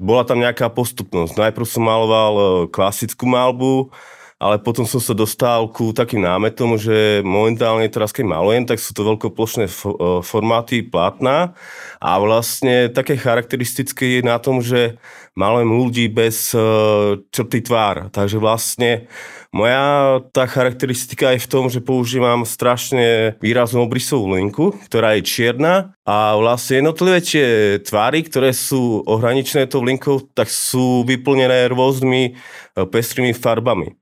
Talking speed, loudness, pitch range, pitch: 130 wpm, -16 LUFS, 110-130 Hz, 120 Hz